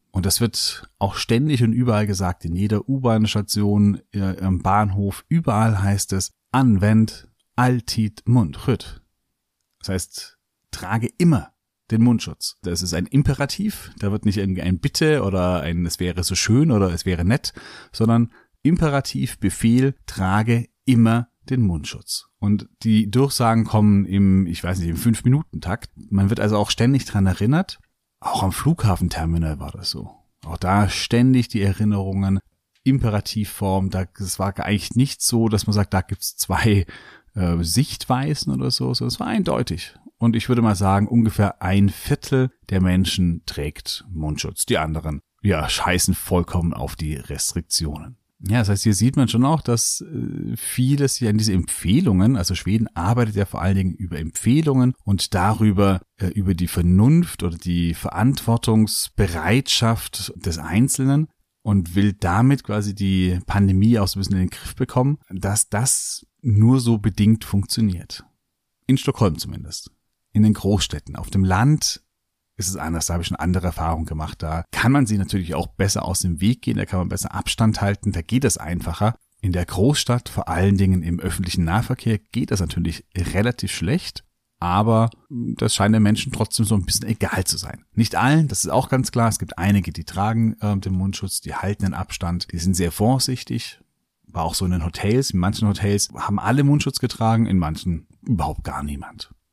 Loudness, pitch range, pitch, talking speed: -21 LUFS, 90-115 Hz, 100 Hz, 170 wpm